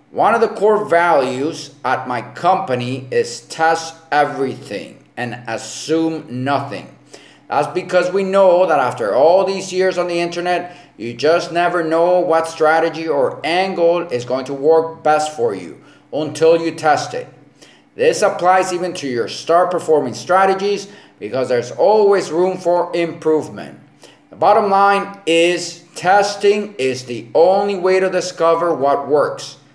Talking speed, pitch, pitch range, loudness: 145 wpm, 170 Hz, 155-190 Hz, -16 LUFS